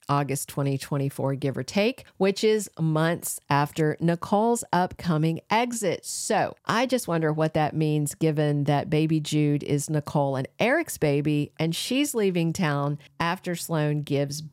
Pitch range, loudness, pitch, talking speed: 145-175 Hz, -25 LUFS, 155 Hz, 145 wpm